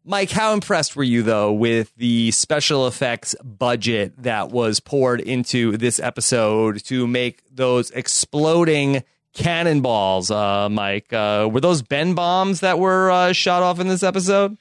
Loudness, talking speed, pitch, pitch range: -19 LUFS, 150 wpm, 130 Hz, 115-175 Hz